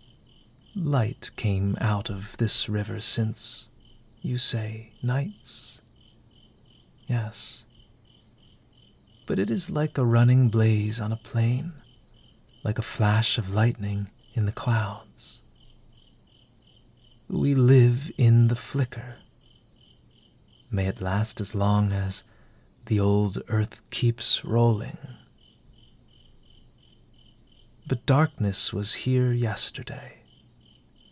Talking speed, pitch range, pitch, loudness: 95 wpm, 110-125 Hz, 115 Hz, -25 LUFS